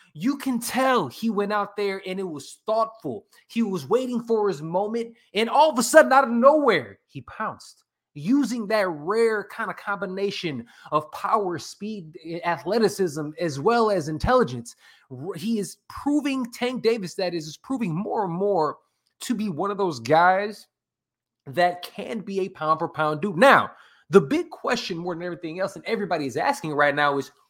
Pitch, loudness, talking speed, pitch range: 200 Hz, -24 LUFS, 180 wpm, 170-230 Hz